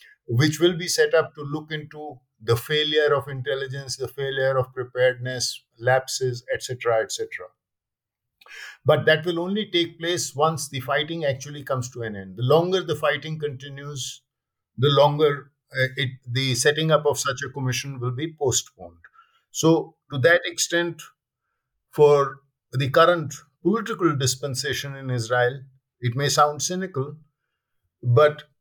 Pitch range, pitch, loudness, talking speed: 130-155 Hz, 145 Hz, -23 LUFS, 140 wpm